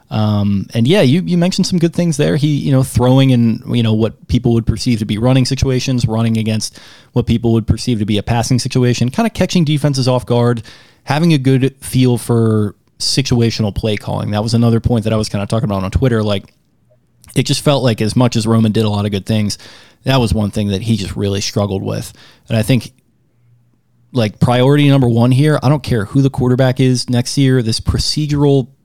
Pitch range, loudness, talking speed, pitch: 110-130 Hz, -14 LUFS, 225 wpm, 120 Hz